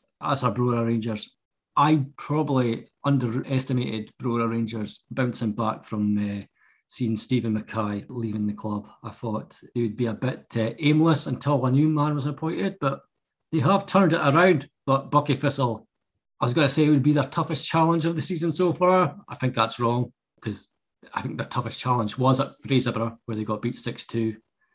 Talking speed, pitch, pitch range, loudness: 185 wpm, 130 Hz, 115-150 Hz, -25 LUFS